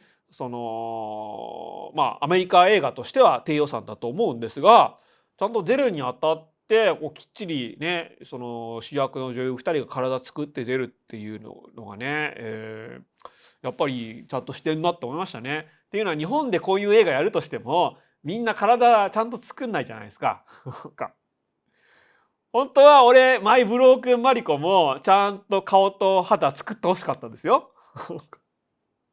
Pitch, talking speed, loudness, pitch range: 155 Hz, 330 characters per minute, -21 LUFS, 125-200 Hz